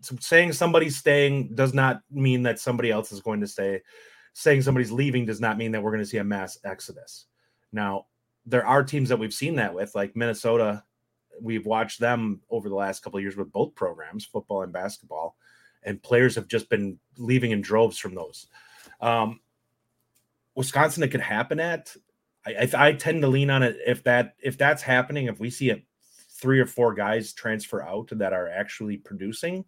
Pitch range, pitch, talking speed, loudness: 110-135 Hz, 120 Hz, 195 wpm, -25 LUFS